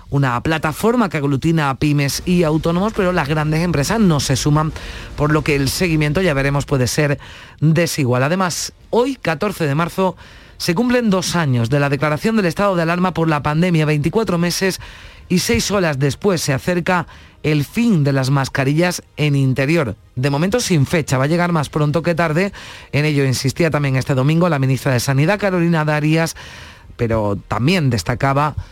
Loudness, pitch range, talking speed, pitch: -17 LUFS, 140-175 Hz, 180 wpm, 155 Hz